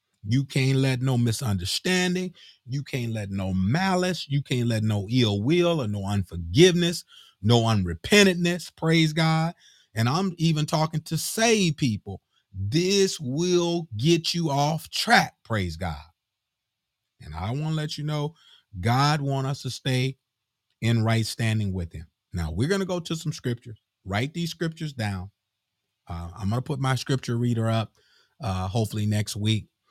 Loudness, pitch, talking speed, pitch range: -25 LUFS, 125 Hz, 160 wpm, 105-160 Hz